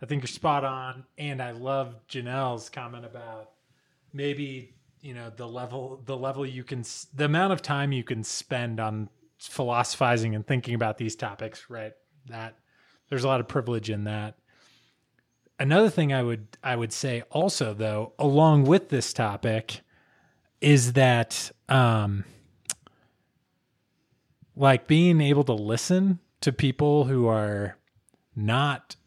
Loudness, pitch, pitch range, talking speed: -26 LUFS, 130 Hz, 115-140 Hz, 140 wpm